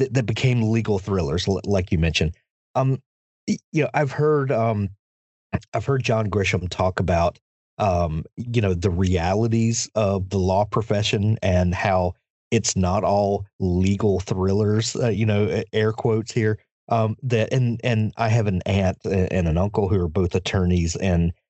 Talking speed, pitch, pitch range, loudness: 160 wpm, 105 Hz, 95-115 Hz, -22 LUFS